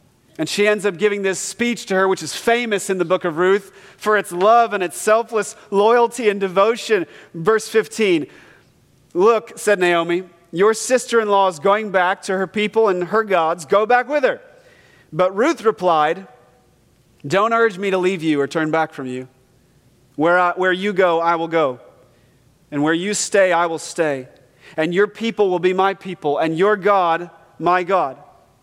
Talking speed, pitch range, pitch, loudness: 185 wpm, 165-215 Hz, 190 Hz, -18 LUFS